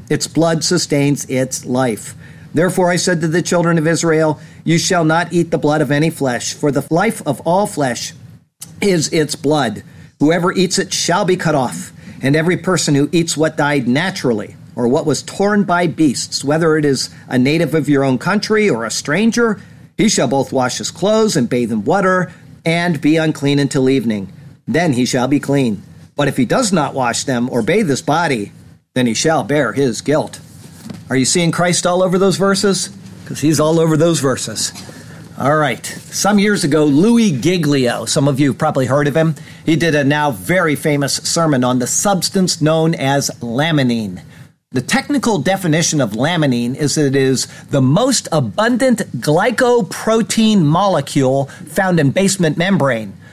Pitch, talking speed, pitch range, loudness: 155 Hz, 180 wpm, 140-175 Hz, -15 LUFS